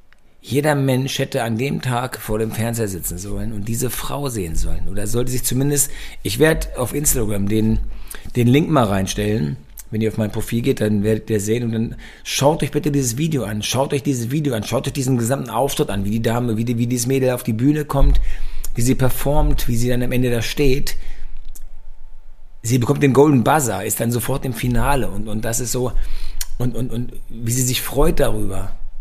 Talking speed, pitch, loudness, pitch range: 215 wpm, 120 Hz, -20 LUFS, 110-135 Hz